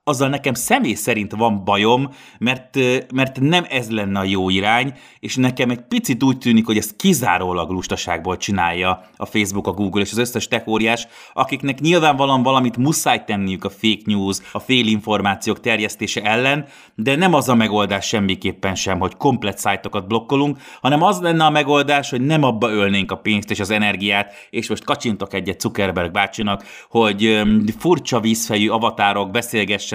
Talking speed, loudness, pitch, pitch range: 160 wpm, -18 LUFS, 110 Hz, 100-130 Hz